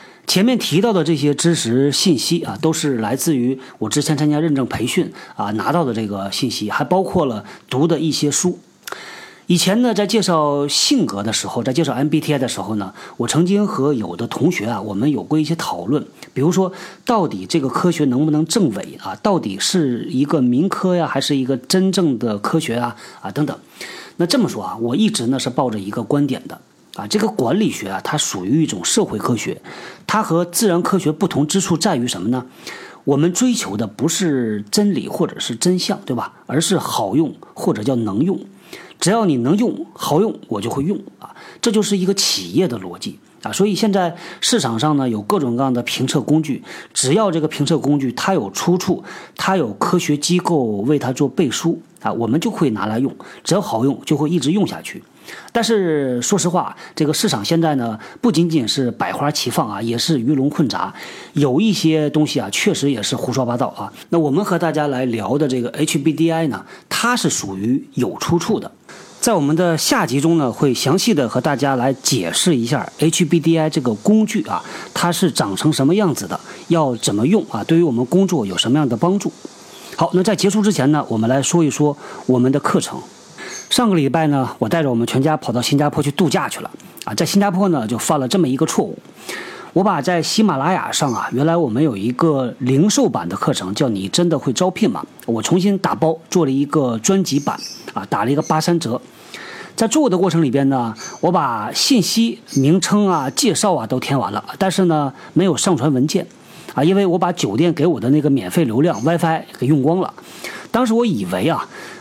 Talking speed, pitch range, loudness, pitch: 300 characters per minute, 135-180 Hz, -18 LUFS, 155 Hz